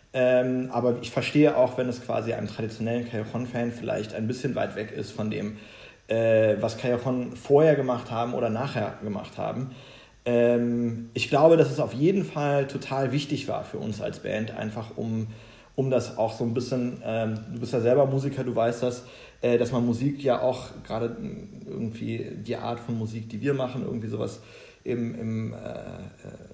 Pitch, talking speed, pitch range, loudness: 120 Hz, 185 wpm, 115-130 Hz, -27 LUFS